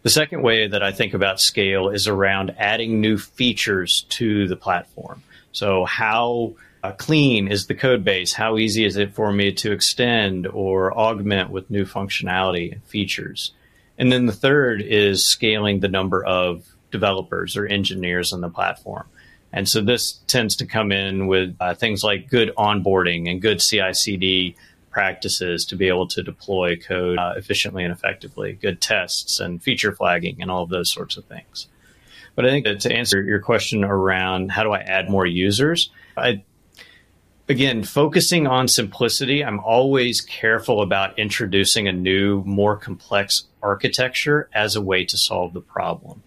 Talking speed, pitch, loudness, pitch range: 170 wpm, 100 Hz, -20 LUFS, 95-110 Hz